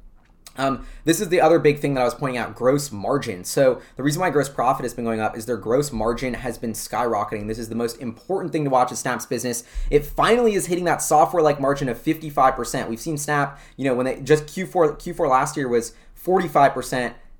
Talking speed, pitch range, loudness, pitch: 230 wpm, 120-150 Hz, -22 LUFS, 130 Hz